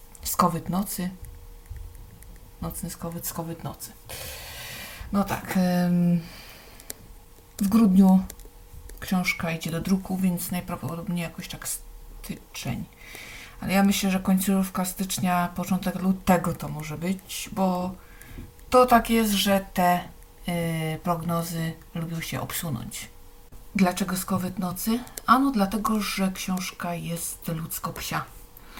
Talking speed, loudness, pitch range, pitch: 105 wpm, -26 LUFS, 165-190 Hz, 180 Hz